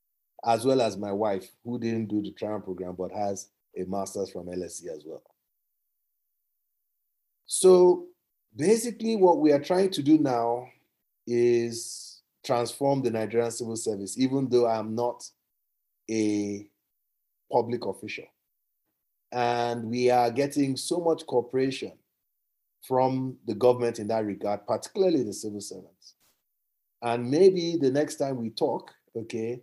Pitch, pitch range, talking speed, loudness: 120 Hz, 110-135 Hz, 135 wpm, -27 LUFS